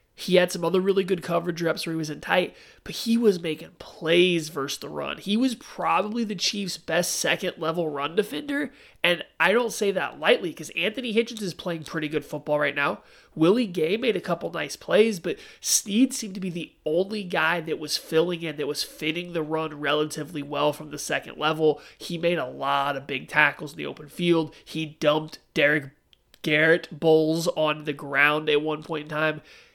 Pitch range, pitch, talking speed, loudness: 150-185 Hz, 160 Hz, 200 wpm, -25 LUFS